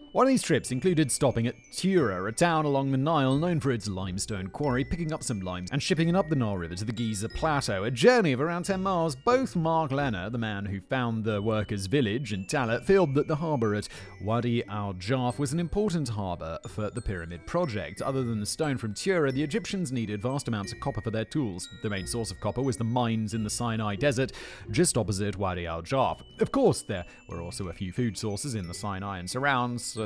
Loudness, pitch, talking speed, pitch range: -28 LUFS, 120 Hz, 225 wpm, 105-150 Hz